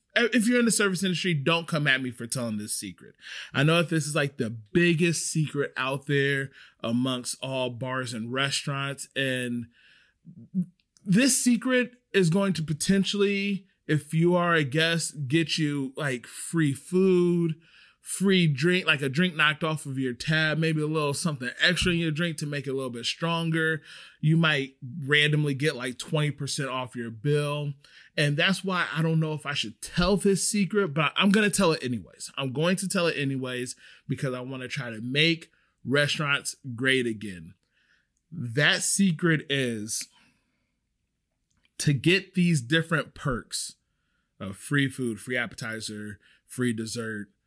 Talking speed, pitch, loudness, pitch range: 165 wpm, 150 Hz, -26 LUFS, 130-170 Hz